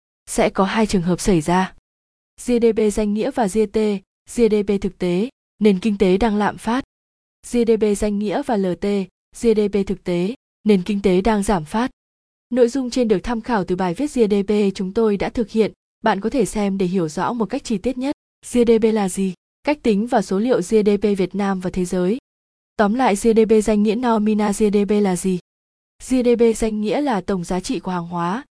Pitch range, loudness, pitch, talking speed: 195-230 Hz, -19 LUFS, 210 Hz, 200 wpm